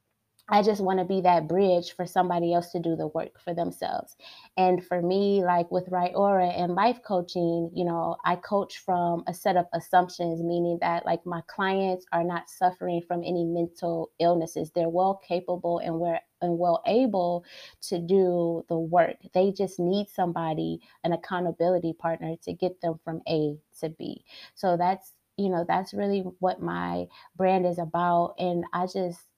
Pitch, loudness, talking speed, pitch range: 175 Hz, -27 LUFS, 175 wpm, 170-185 Hz